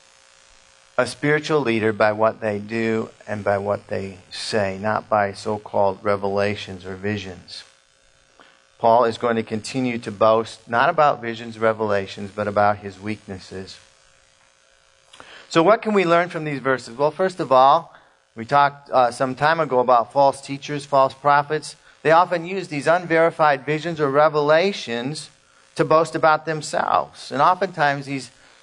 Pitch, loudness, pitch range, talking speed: 115 Hz, -20 LUFS, 100-150 Hz, 150 wpm